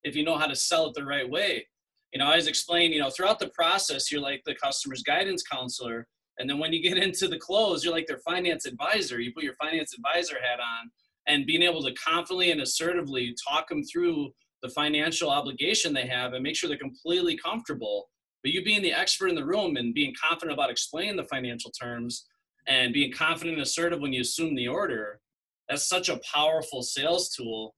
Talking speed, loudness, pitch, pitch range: 215 wpm, -27 LUFS, 160 Hz, 130-185 Hz